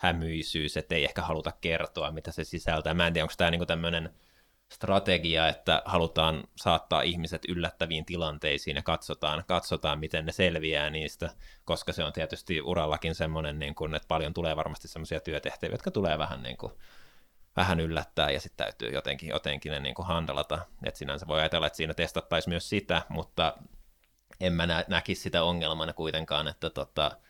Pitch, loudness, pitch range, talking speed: 80 Hz, -30 LUFS, 80-85 Hz, 170 wpm